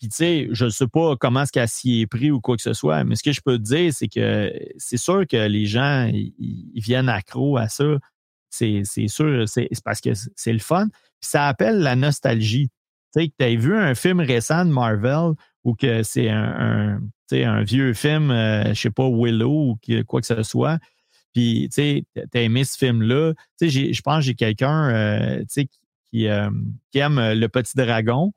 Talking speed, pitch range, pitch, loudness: 220 wpm, 115-145 Hz, 125 Hz, -21 LUFS